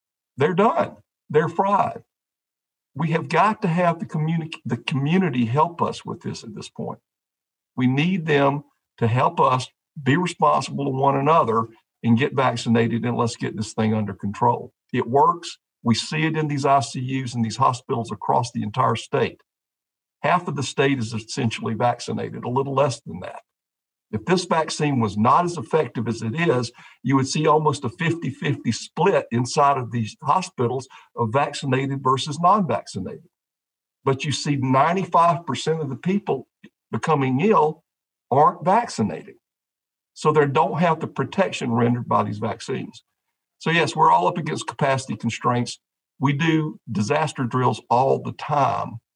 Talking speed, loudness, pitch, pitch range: 160 wpm, -22 LUFS, 135 Hz, 120-155 Hz